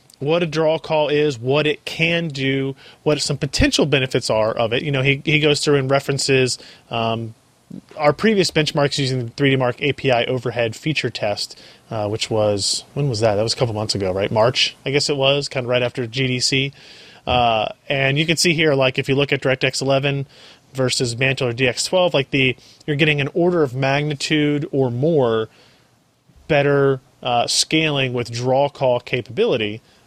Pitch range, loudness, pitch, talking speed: 125-145 Hz, -19 LUFS, 135 Hz, 185 wpm